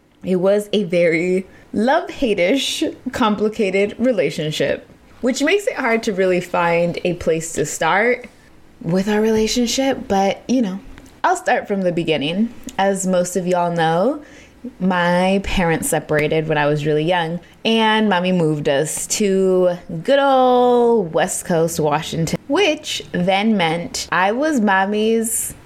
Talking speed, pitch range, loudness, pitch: 135 wpm, 170-235 Hz, -18 LUFS, 195 Hz